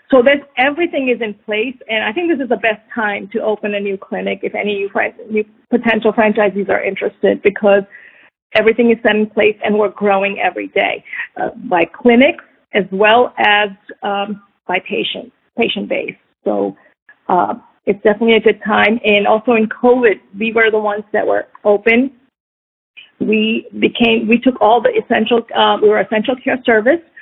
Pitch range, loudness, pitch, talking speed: 210-240 Hz, -15 LUFS, 220 Hz, 175 wpm